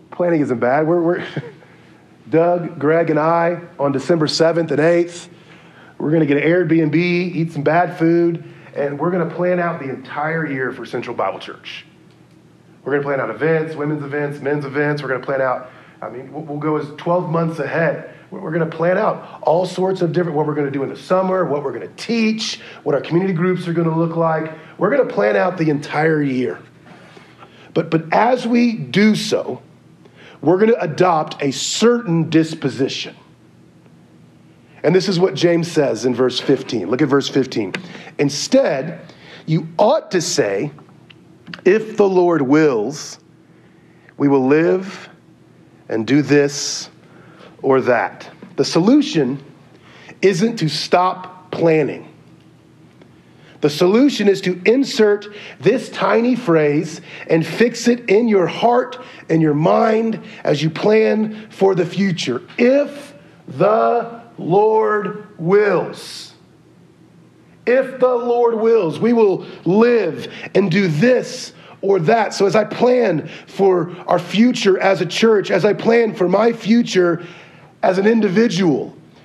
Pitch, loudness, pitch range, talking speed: 170 Hz, -17 LUFS, 155-205 Hz, 155 wpm